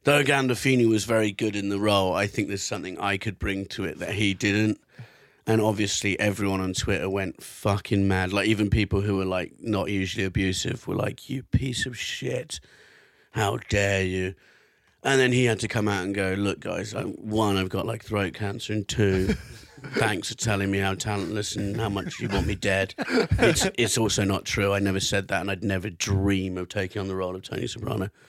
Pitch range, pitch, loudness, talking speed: 95-110 Hz, 100 Hz, -26 LUFS, 210 wpm